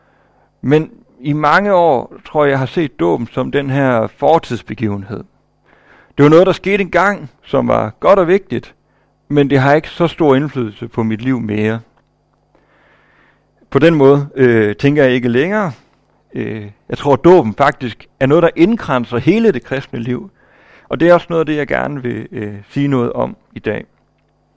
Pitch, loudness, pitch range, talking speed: 140 Hz, -14 LUFS, 120-160 Hz, 175 wpm